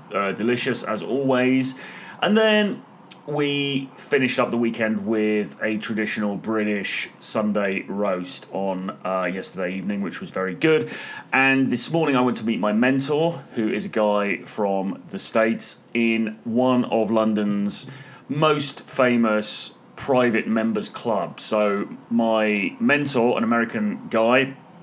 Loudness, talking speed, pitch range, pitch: -22 LUFS, 135 wpm, 105-130 Hz, 115 Hz